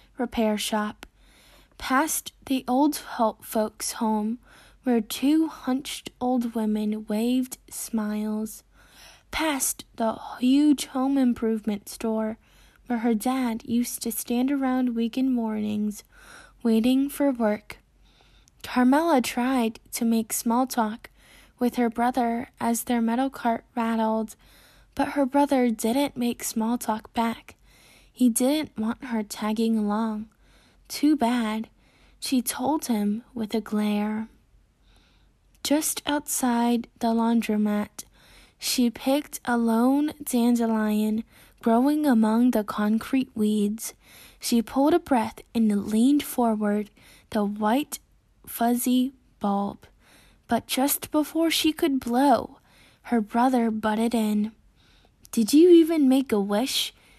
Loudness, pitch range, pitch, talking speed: -25 LUFS, 220-265 Hz, 235 Hz, 115 wpm